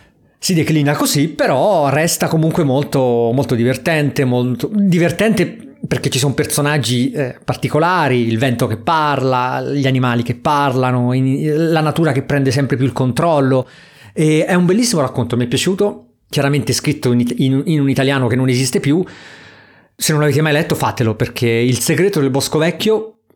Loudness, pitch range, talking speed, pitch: -15 LUFS, 130-160 Hz, 165 wpm, 140 Hz